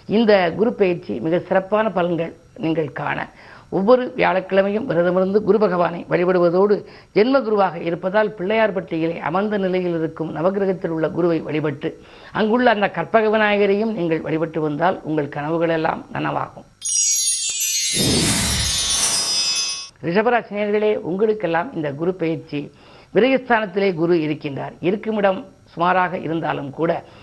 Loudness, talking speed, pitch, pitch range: -19 LUFS, 105 wpm, 180 Hz, 165-210 Hz